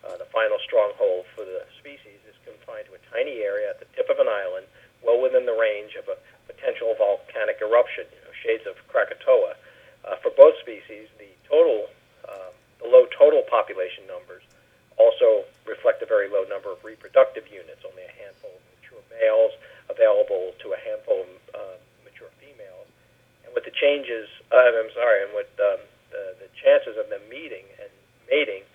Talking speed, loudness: 180 wpm, -22 LUFS